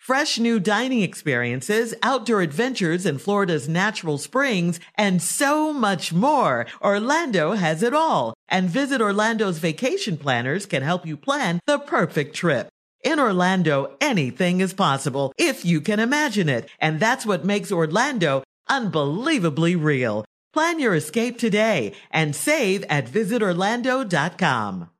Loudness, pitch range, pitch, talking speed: -21 LUFS, 160-235 Hz, 200 Hz, 130 wpm